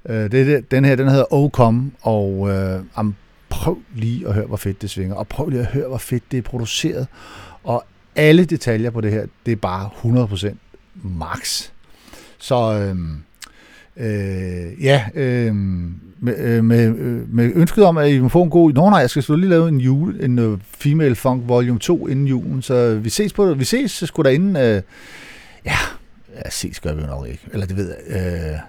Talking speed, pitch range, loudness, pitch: 205 wpm, 100-140 Hz, -18 LUFS, 120 Hz